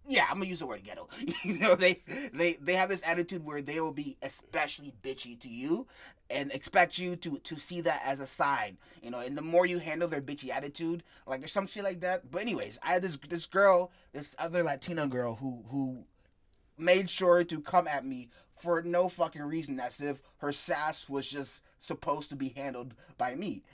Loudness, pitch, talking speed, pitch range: -32 LUFS, 155 Hz, 210 wpm, 135-180 Hz